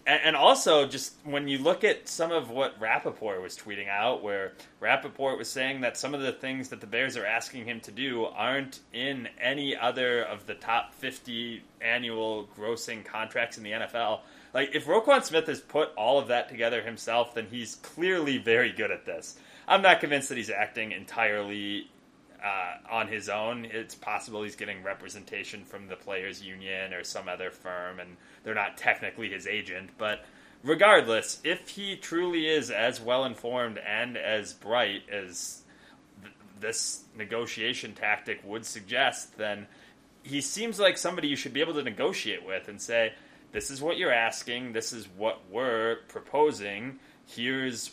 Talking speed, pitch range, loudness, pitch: 170 wpm, 105-140 Hz, -29 LUFS, 120 Hz